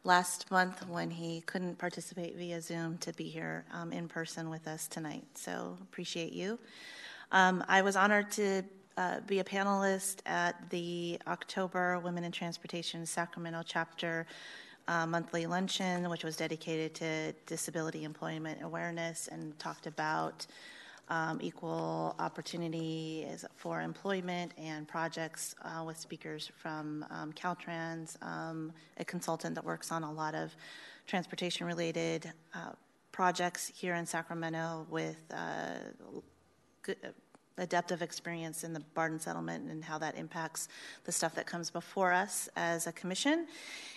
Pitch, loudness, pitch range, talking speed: 170 Hz, -37 LUFS, 160-180 Hz, 135 wpm